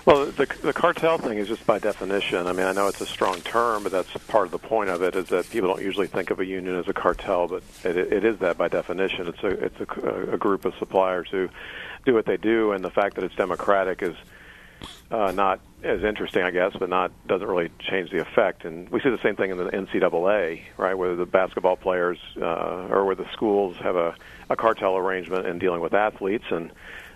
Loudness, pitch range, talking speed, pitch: -24 LUFS, 90-100 Hz, 235 wpm, 95 Hz